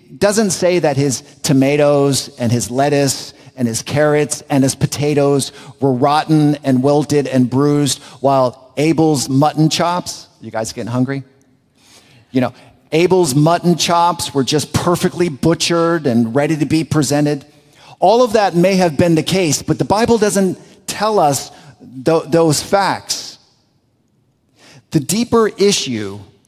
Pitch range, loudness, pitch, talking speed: 135-170 Hz, -15 LUFS, 145 Hz, 140 wpm